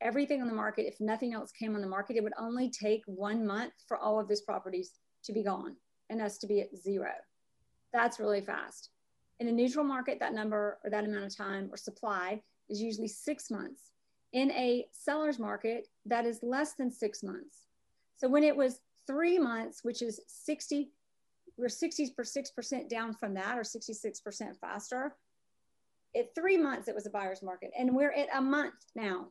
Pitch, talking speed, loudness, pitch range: 230 Hz, 190 wpm, -35 LUFS, 210-270 Hz